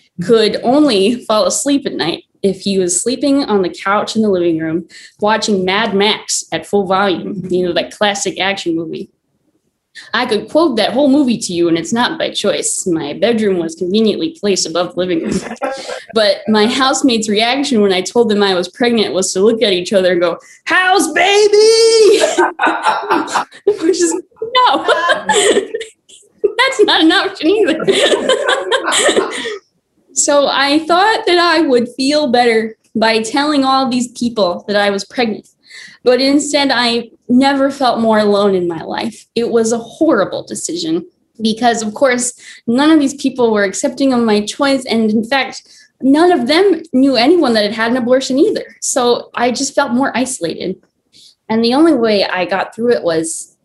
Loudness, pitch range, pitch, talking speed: -13 LUFS, 205-300 Hz, 240 Hz, 170 wpm